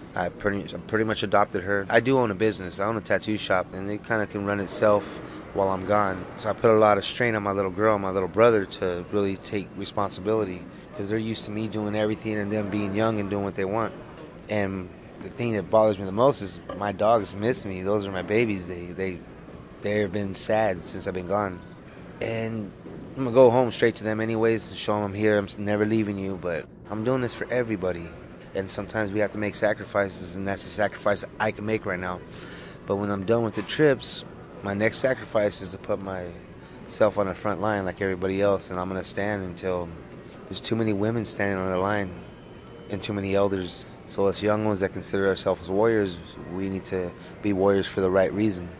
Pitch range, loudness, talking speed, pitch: 95-110 Hz, -26 LUFS, 225 wpm, 100 Hz